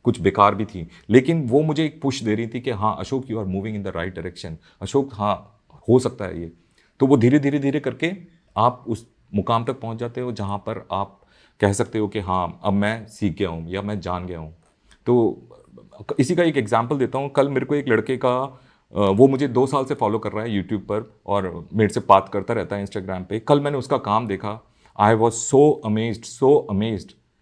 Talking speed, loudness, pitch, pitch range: 225 wpm, -21 LUFS, 110 Hz, 100-130 Hz